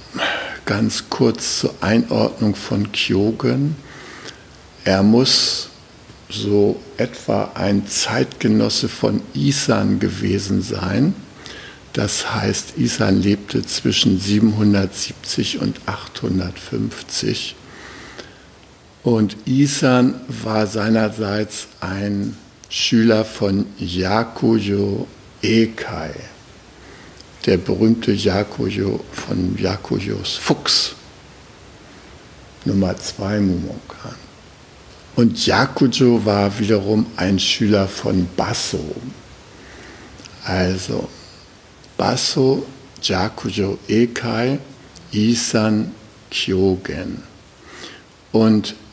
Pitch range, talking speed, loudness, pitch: 100-115 Hz, 70 wpm, -19 LUFS, 105 Hz